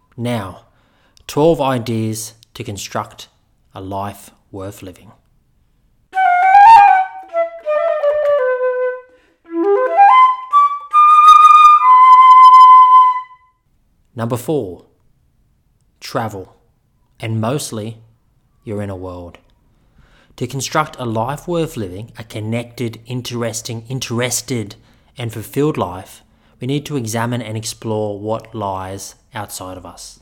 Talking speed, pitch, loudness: 80 wpm, 120 Hz, -12 LUFS